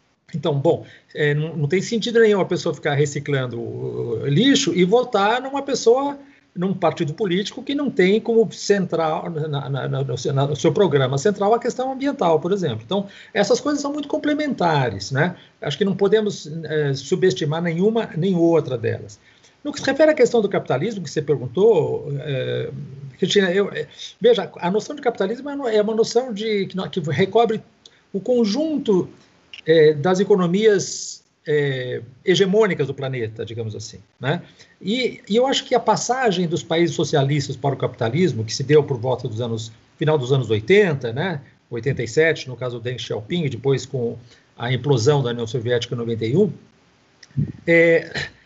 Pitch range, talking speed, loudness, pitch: 140-210 Hz, 160 wpm, -20 LUFS, 165 Hz